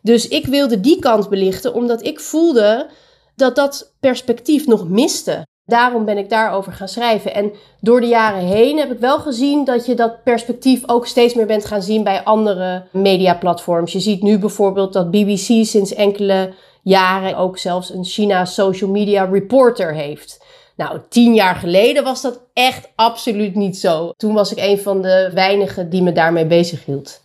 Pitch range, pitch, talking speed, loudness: 190-240 Hz, 210 Hz, 175 wpm, -15 LUFS